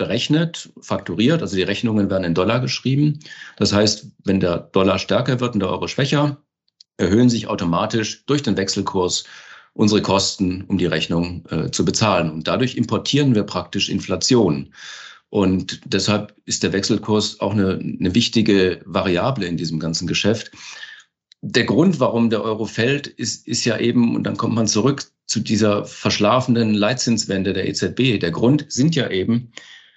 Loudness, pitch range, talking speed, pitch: -19 LUFS, 95-120 Hz, 160 wpm, 105 Hz